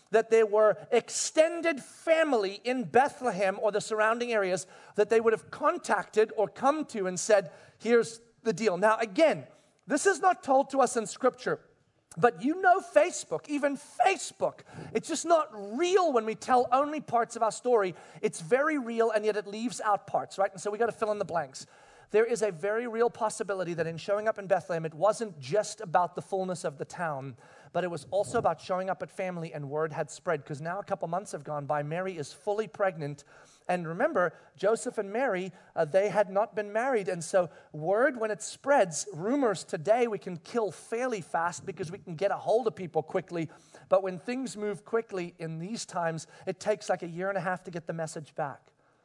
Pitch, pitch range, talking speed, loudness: 205 Hz, 180-230 Hz, 210 wpm, -29 LUFS